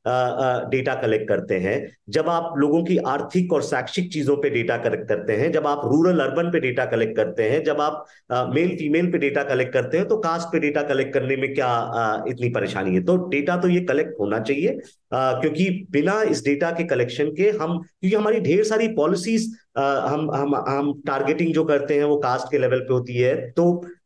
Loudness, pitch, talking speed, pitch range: -22 LUFS, 150 Hz, 220 wpm, 135-175 Hz